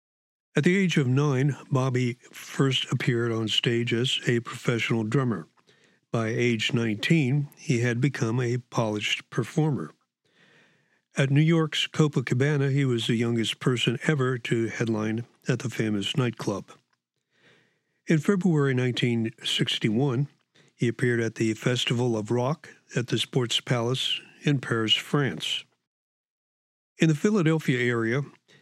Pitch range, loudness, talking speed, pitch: 115-145 Hz, -26 LUFS, 125 wpm, 125 Hz